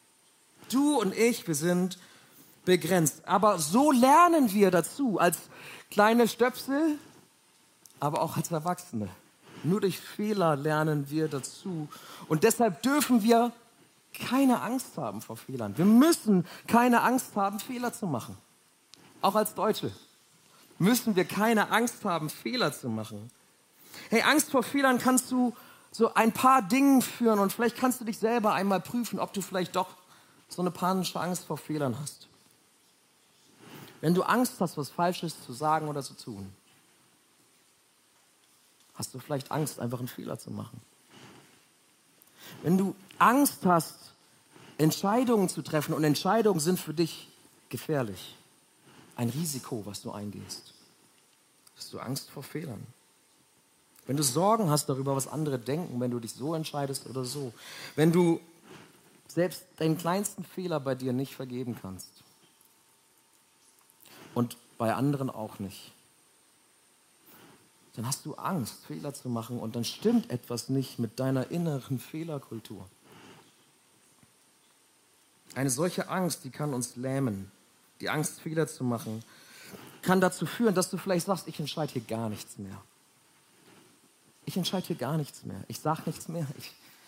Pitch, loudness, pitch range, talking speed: 165 Hz, -28 LUFS, 135-200 Hz, 145 wpm